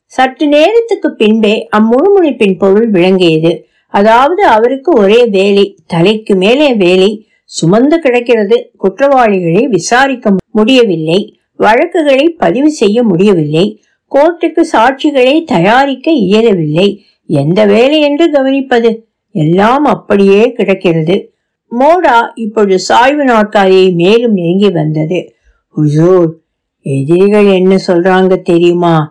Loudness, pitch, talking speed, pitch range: -8 LUFS, 210 Hz, 90 wpm, 185-255 Hz